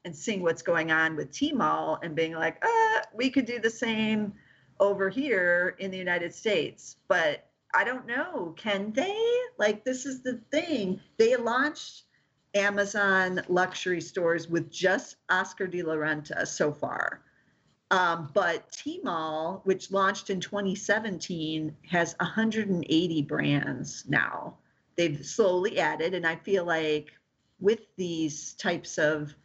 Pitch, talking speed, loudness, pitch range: 185 Hz, 145 wpm, -28 LUFS, 165-215 Hz